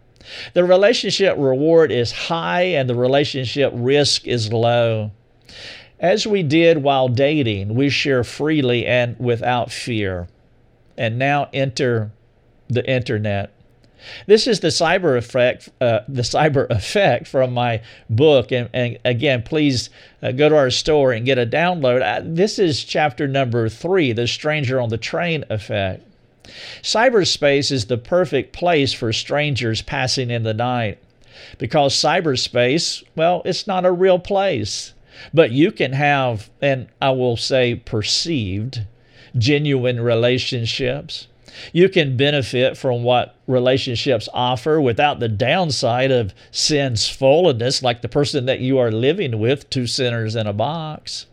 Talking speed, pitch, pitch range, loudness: 140 wpm, 130 Hz, 120-145 Hz, -18 LUFS